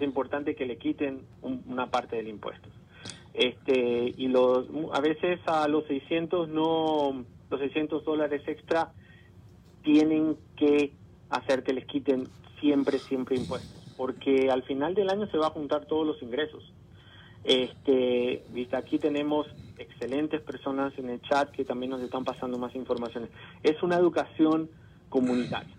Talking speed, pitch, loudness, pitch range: 145 wpm, 140 Hz, -29 LUFS, 125-155 Hz